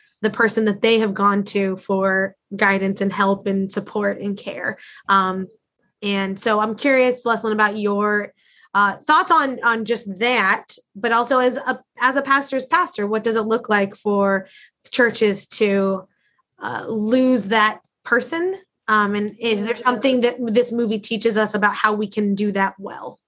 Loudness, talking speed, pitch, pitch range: -19 LUFS, 170 wpm, 215 Hz, 200-240 Hz